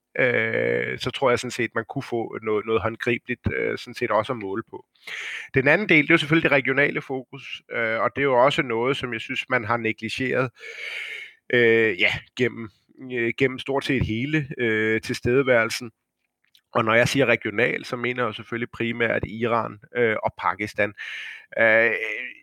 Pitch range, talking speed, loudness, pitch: 115-145 Hz, 175 wpm, -23 LUFS, 125 Hz